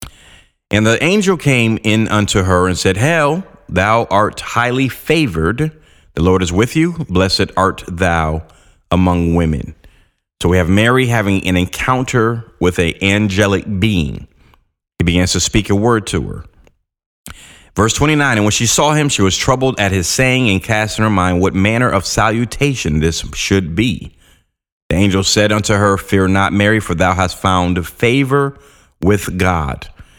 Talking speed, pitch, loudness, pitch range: 165 wpm, 100 Hz, -14 LUFS, 90-115 Hz